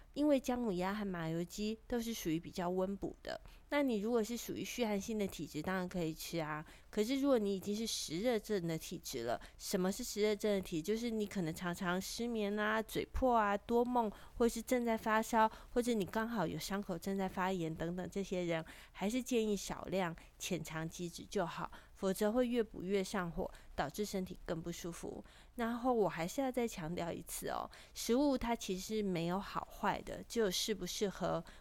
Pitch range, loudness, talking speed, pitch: 180-230 Hz, -38 LUFS, 295 characters per minute, 200 Hz